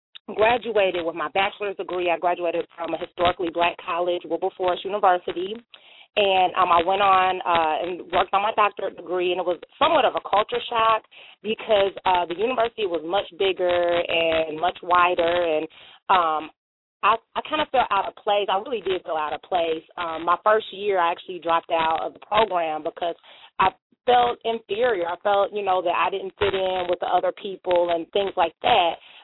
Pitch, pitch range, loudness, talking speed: 180 Hz, 170-205 Hz, -23 LUFS, 190 wpm